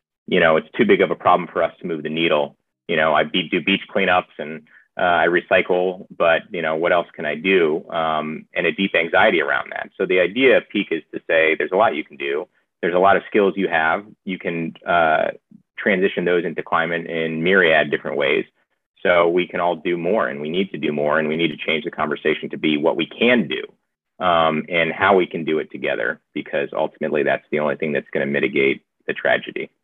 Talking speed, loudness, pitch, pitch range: 235 wpm, -19 LUFS, 80 Hz, 80-85 Hz